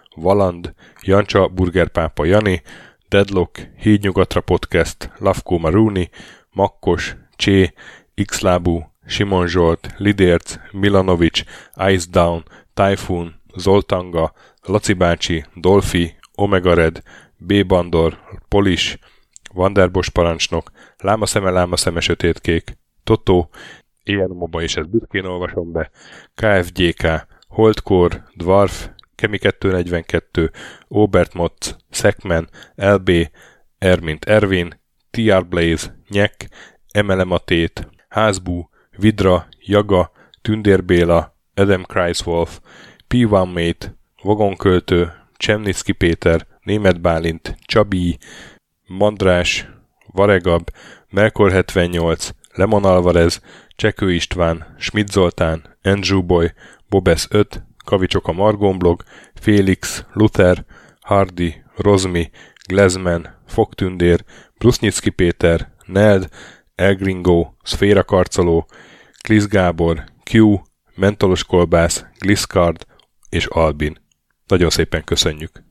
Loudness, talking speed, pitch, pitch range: -17 LUFS, 85 wpm, 90 Hz, 85-100 Hz